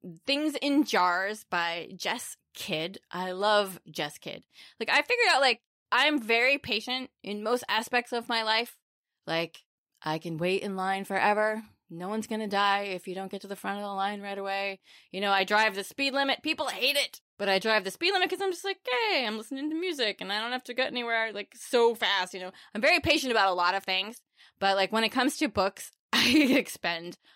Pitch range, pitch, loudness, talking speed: 195-260 Hz, 215 Hz, -28 LUFS, 220 wpm